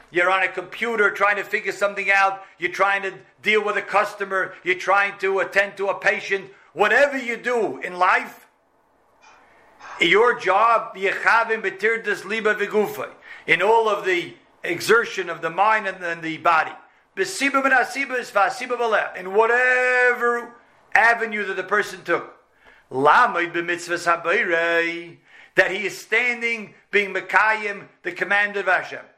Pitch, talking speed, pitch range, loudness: 200 Hz, 120 wpm, 185-225 Hz, -20 LUFS